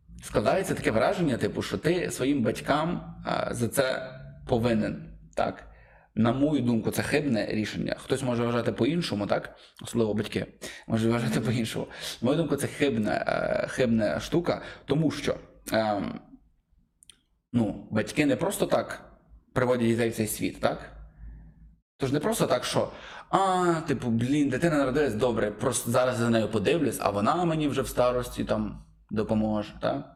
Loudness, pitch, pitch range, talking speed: -27 LUFS, 115 Hz, 110-130 Hz, 145 wpm